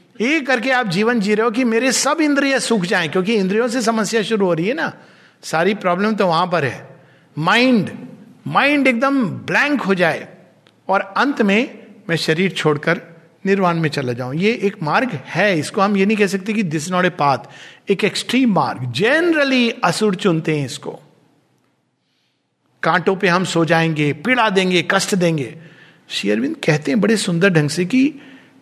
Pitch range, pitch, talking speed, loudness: 165-230 Hz, 195 Hz, 170 wpm, -17 LUFS